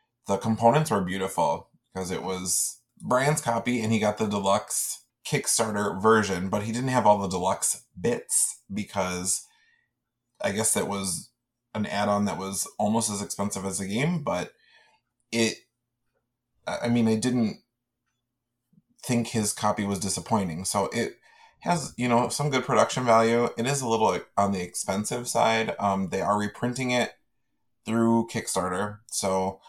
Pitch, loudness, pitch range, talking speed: 110 Hz, -26 LUFS, 100-120 Hz, 155 wpm